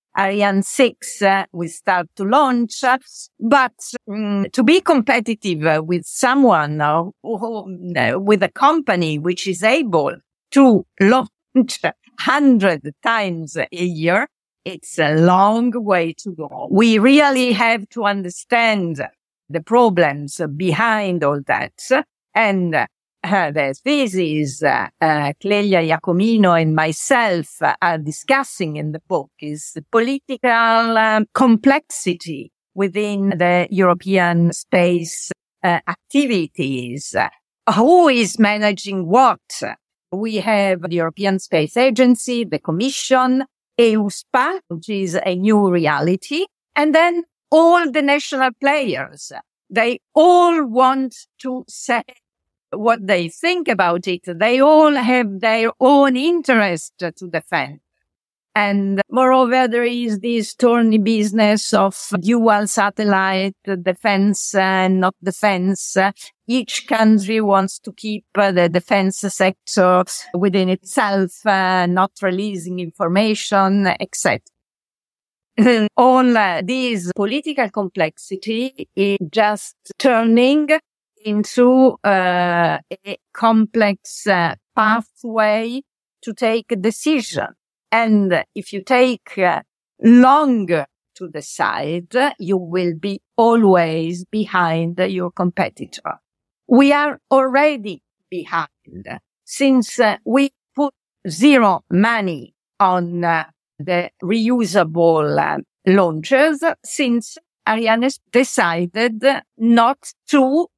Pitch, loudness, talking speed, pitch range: 205 Hz, -17 LUFS, 110 wpm, 180-250 Hz